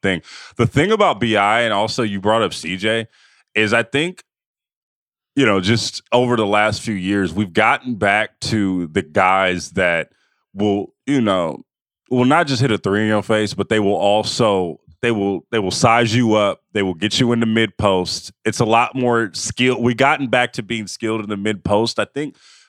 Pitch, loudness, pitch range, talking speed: 110 Hz, -18 LUFS, 100-120 Hz, 205 wpm